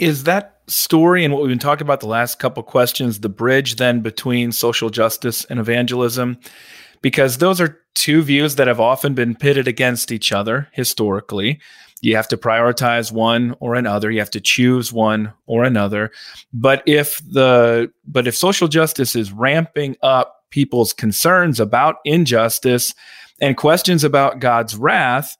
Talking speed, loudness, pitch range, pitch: 165 wpm, -16 LUFS, 115-145 Hz, 125 Hz